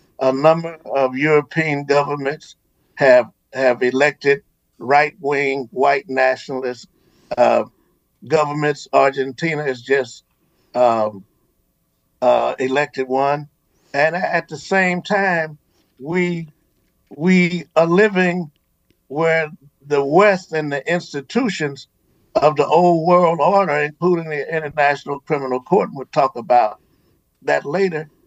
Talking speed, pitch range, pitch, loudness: 105 wpm, 135-165 Hz, 145 Hz, -18 LUFS